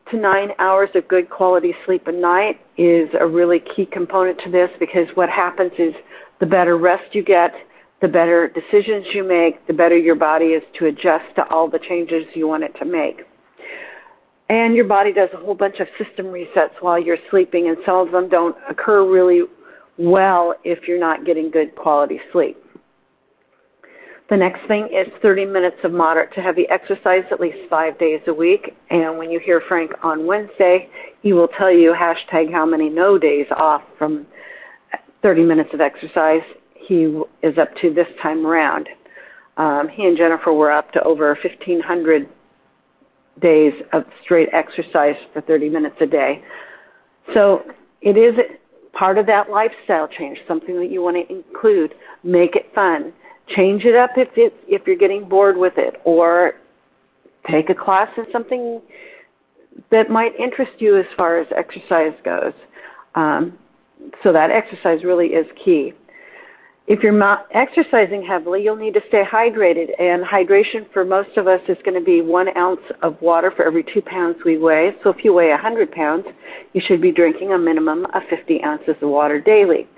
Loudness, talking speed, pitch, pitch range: -16 LUFS, 175 wpm, 180 Hz, 165-205 Hz